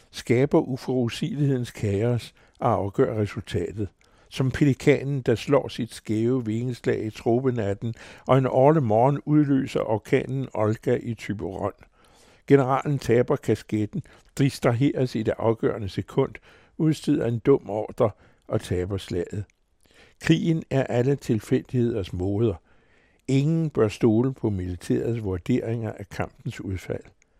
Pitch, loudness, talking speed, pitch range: 120 Hz, -25 LUFS, 115 wpm, 105-135 Hz